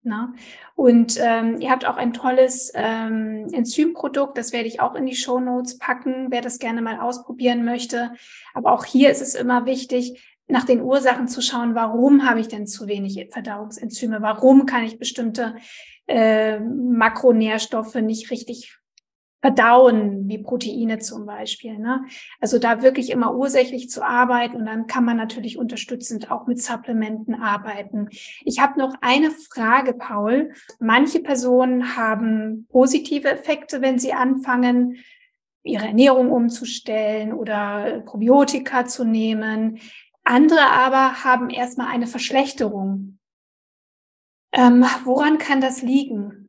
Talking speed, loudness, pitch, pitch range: 135 wpm, -19 LUFS, 245 Hz, 225-260 Hz